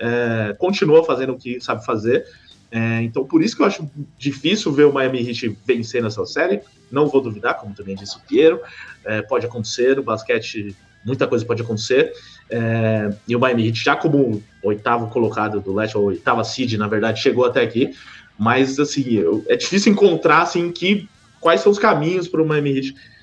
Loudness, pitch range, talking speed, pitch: -19 LUFS, 110-155 Hz, 190 wpm, 120 Hz